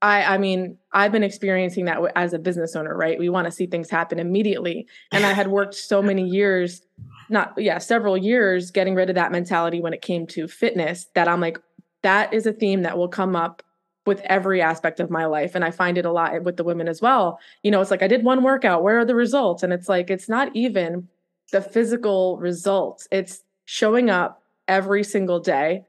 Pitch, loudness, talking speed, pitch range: 185 Hz, -21 LUFS, 220 wpm, 170-200 Hz